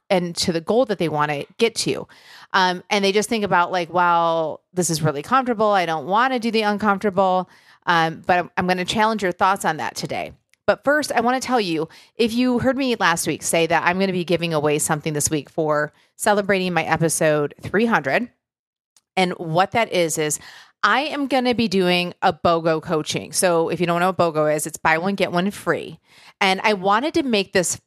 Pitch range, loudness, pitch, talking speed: 165-210 Hz, -20 LUFS, 185 Hz, 225 wpm